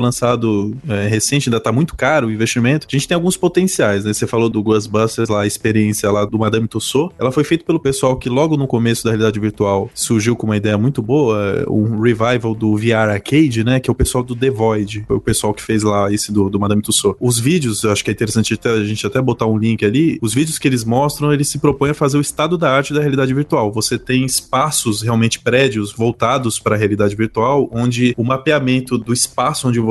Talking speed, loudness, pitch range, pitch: 235 wpm, -16 LUFS, 110-135 Hz, 115 Hz